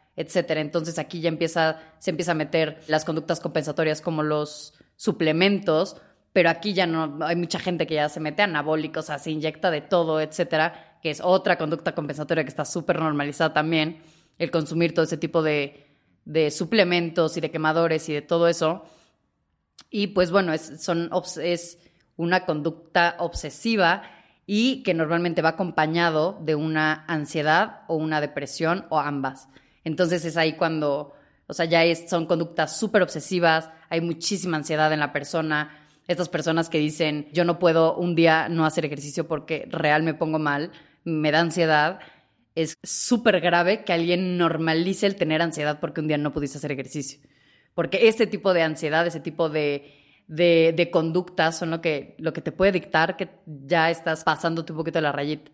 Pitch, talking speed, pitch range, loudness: 160 Hz, 175 wpm, 155-175 Hz, -24 LUFS